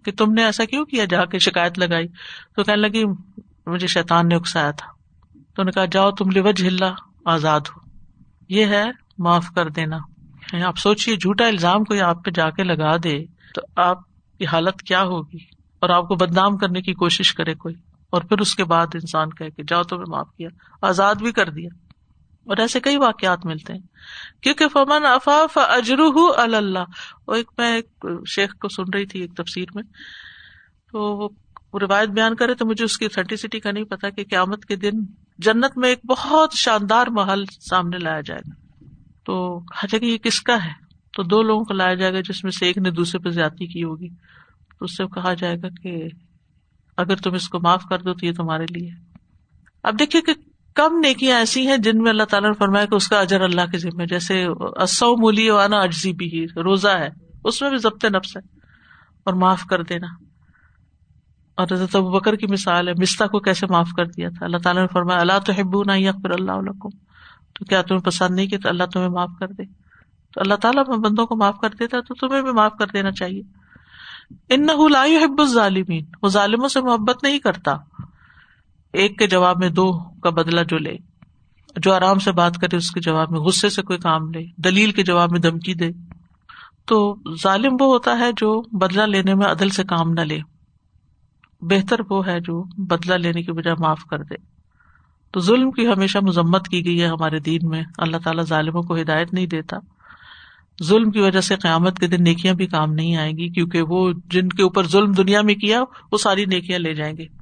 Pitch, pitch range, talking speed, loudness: 190 Hz, 175-210 Hz, 205 wpm, -19 LUFS